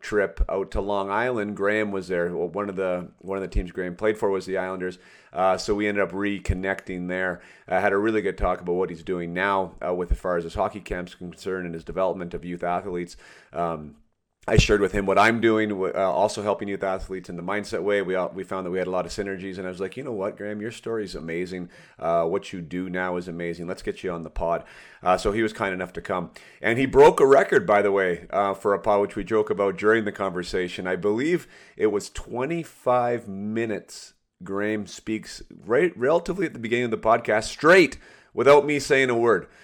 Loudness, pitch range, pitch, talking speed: -24 LUFS, 90-105 Hz, 95 Hz, 240 wpm